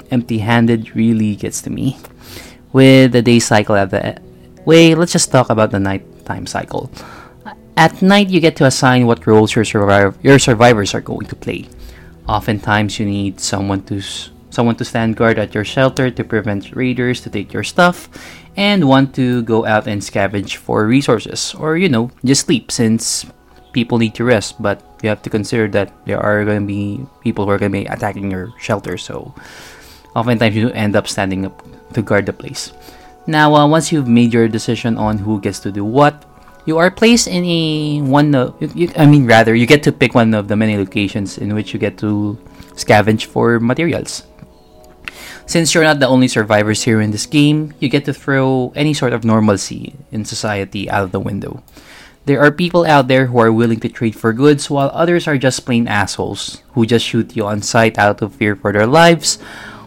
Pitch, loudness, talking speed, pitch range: 115 Hz, -14 LUFS, 195 wpm, 105-135 Hz